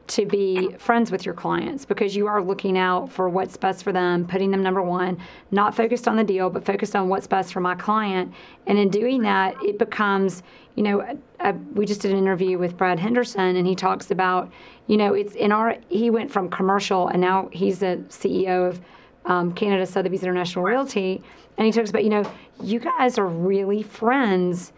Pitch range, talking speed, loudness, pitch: 185-210 Hz, 210 wpm, -22 LUFS, 195 Hz